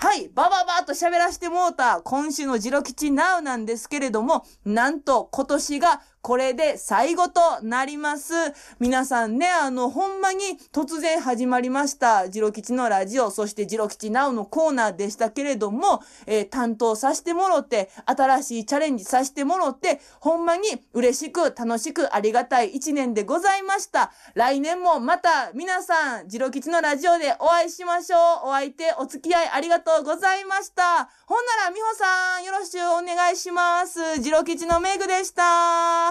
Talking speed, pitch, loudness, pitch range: 350 characters per minute, 300 Hz, -22 LUFS, 250-345 Hz